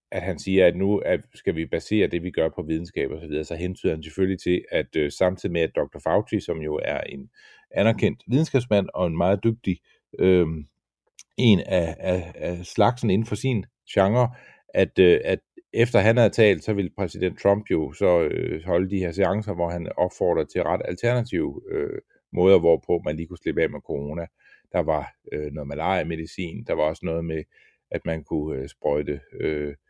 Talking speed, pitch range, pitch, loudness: 200 wpm, 80-110 Hz, 95 Hz, -24 LUFS